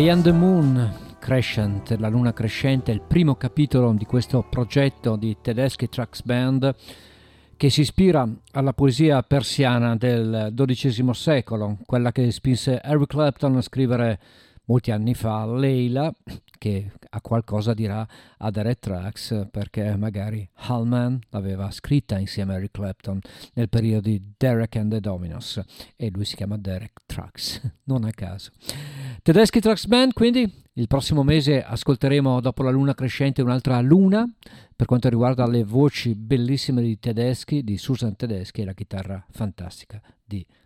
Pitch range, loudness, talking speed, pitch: 110-135 Hz, -22 LUFS, 150 wpm, 120 Hz